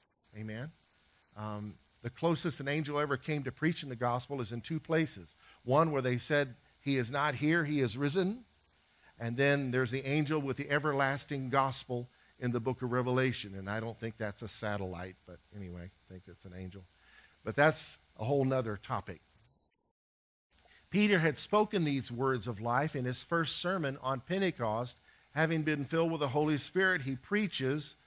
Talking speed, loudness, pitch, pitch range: 175 wpm, -33 LUFS, 130 Hz, 110-150 Hz